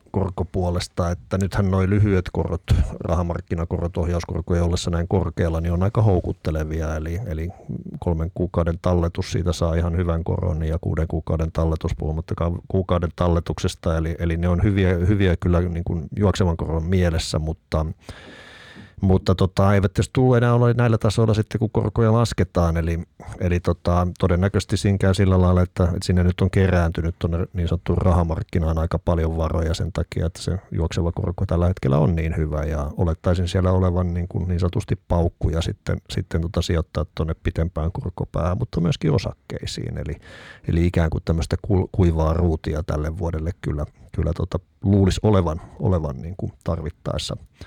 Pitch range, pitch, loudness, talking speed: 85-95 Hz, 90 Hz, -22 LUFS, 160 wpm